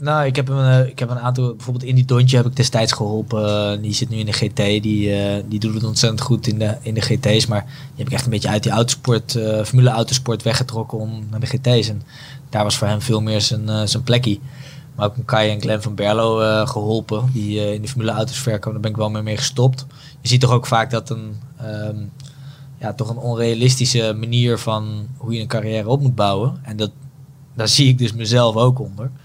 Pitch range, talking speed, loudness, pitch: 110-130 Hz, 235 wpm, -18 LUFS, 115 Hz